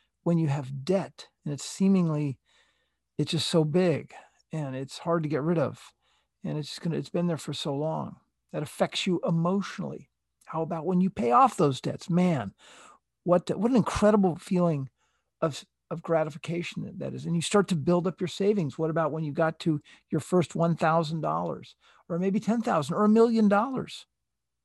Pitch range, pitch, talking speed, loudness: 155-185 Hz, 170 Hz, 190 wpm, -27 LUFS